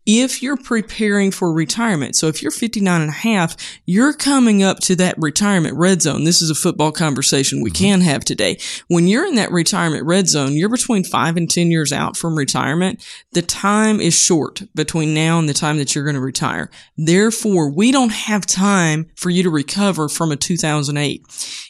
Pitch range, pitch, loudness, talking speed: 155-200 Hz, 175 Hz, -16 LUFS, 195 wpm